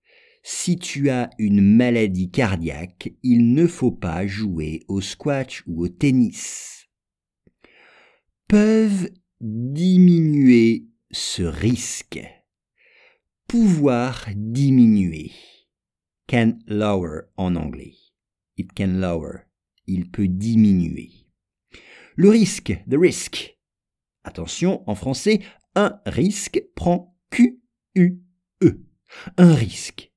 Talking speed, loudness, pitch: 95 wpm, -20 LUFS, 125 Hz